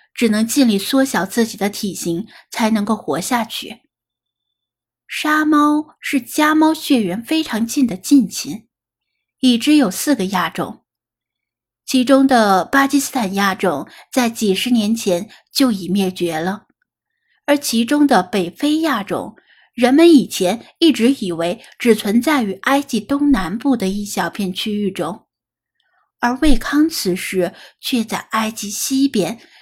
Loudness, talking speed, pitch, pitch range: -17 LUFS, 200 characters per minute, 230 Hz, 190-275 Hz